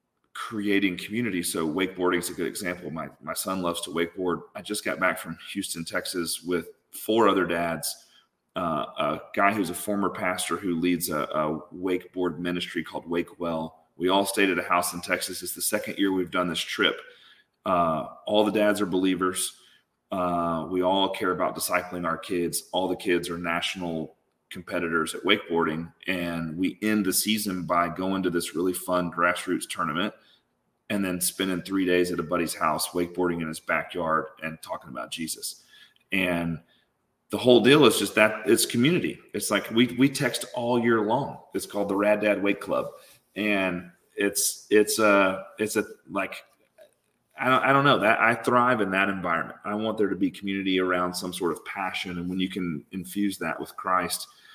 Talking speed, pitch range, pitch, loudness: 185 wpm, 85-100 Hz, 90 Hz, -26 LUFS